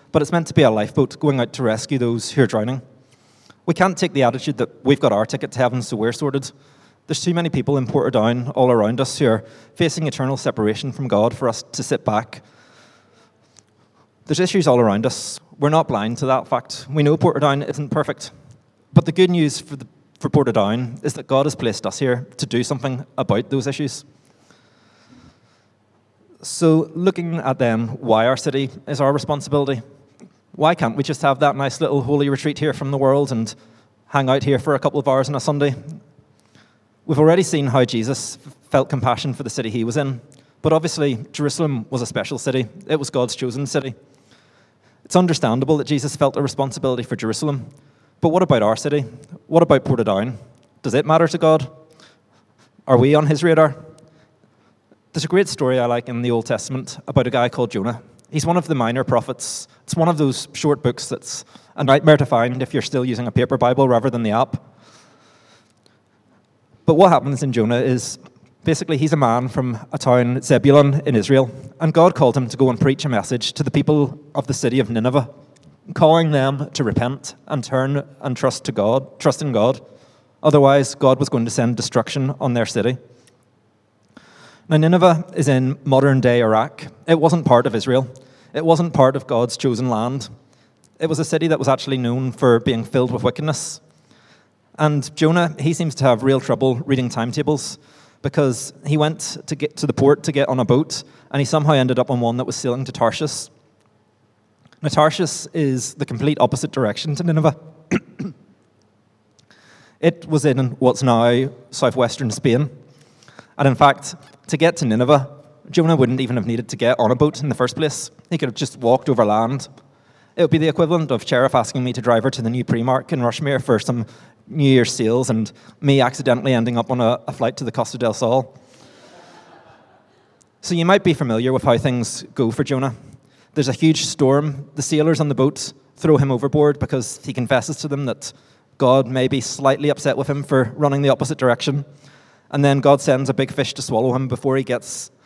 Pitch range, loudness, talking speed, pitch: 125-150 Hz, -19 LUFS, 195 wpm, 135 Hz